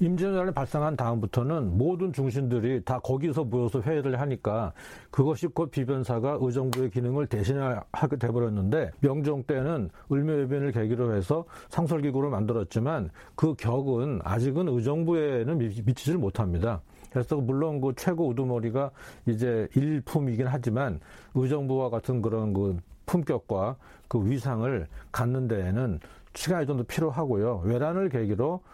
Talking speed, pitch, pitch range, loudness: 325 characters per minute, 130 Hz, 115-150 Hz, -28 LUFS